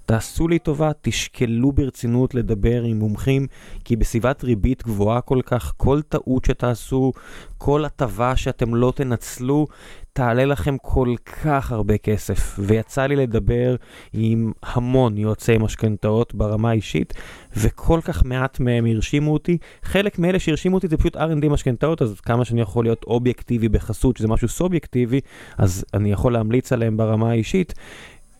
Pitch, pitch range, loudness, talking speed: 125 Hz, 110-135 Hz, -21 LUFS, 145 wpm